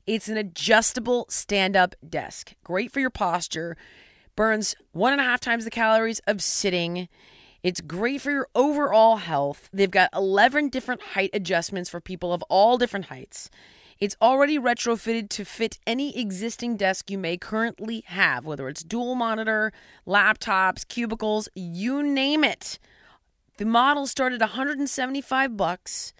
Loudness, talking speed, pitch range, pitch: -24 LUFS, 150 wpm, 190-245 Hz, 220 Hz